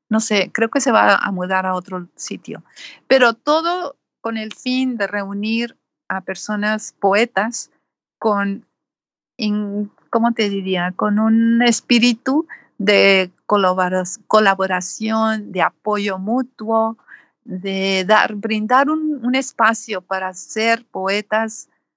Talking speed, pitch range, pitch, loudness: 115 wpm, 195-230 Hz, 215 Hz, -18 LUFS